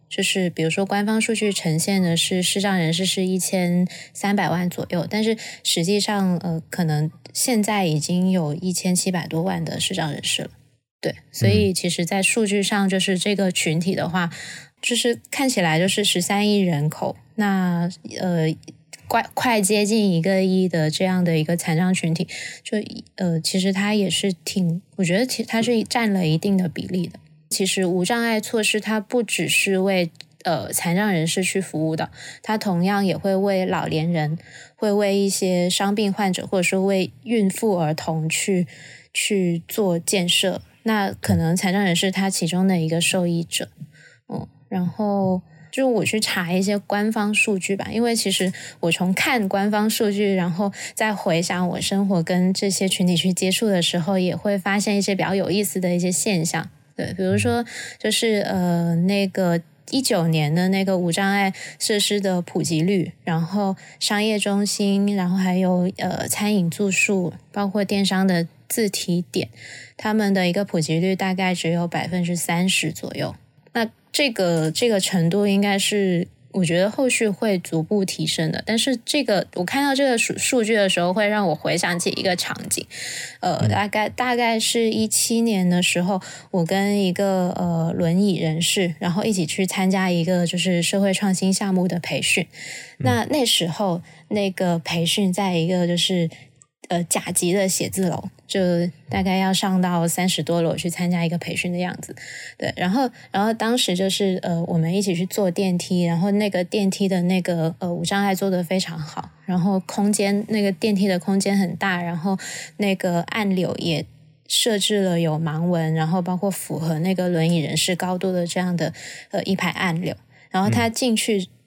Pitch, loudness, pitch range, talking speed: 185 Hz, -21 LUFS, 170-200 Hz, 260 characters per minute